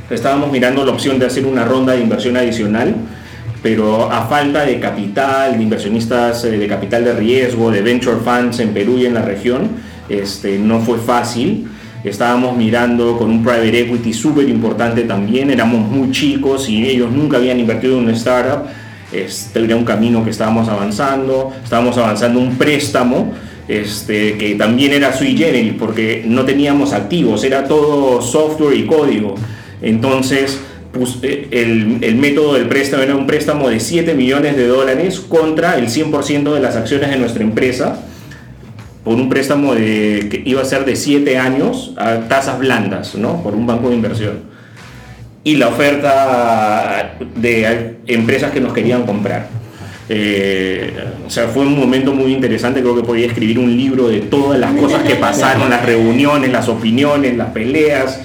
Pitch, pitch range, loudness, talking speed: 120 Hz, 115-135 Hz, -14 LUFS, 165 wpm